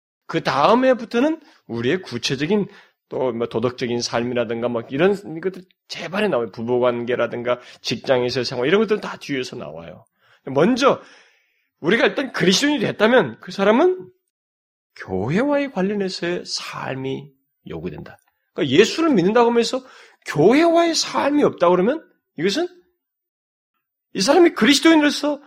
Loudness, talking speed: -19 LUFS, 320 characters per minute